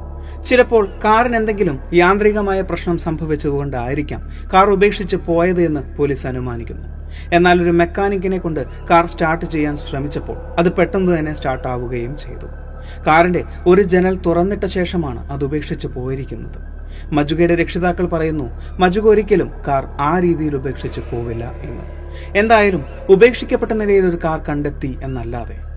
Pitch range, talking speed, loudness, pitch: 130-185 Hz, 120 wpm, -17 LUFS, 165 Hz